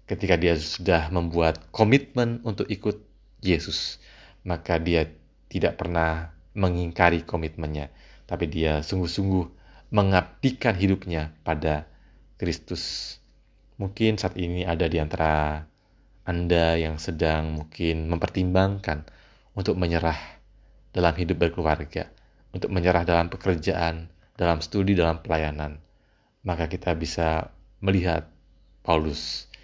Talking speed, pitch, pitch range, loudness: 100 wpm, 85 Hz, 80-95 Hz, -26 LUFS